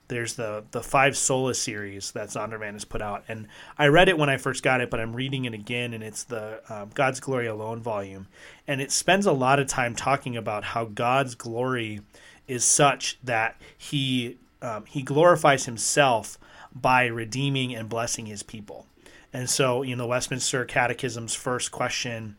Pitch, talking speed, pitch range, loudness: 125 Hz, 185 wpm, 110-135 Hz, -25 LUFS